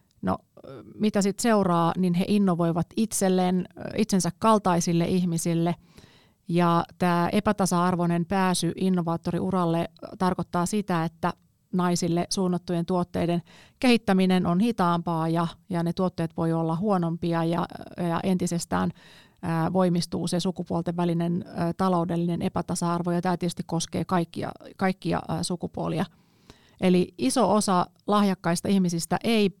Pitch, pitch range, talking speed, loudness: 175 Hz, 170-190 Hz, 115 wpm, -25 LUFS